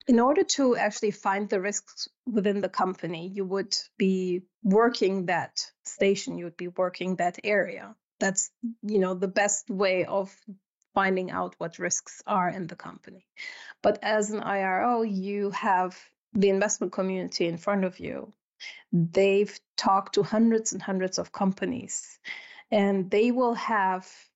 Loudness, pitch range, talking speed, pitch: -27 LUFS, 185-215 Hz, 155 wpm, 200 Hz